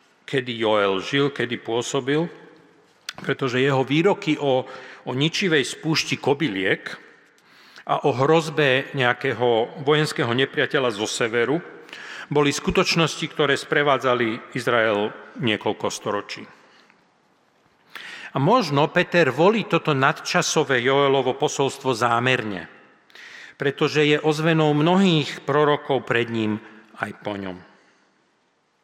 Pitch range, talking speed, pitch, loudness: 130-155 Hz, 100 wpm, 140 Hz, -21 LUFS